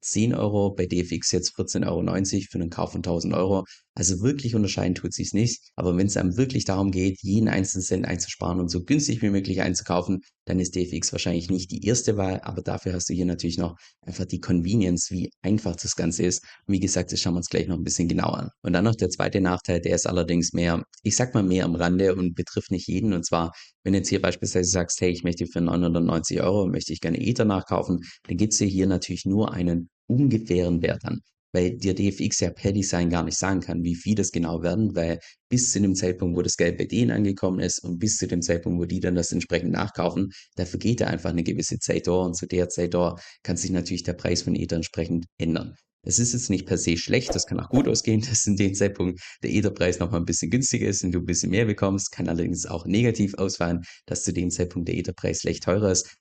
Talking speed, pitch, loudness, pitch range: 240 wpm, 90 Hz, -25 LUFS, 85-100 Hz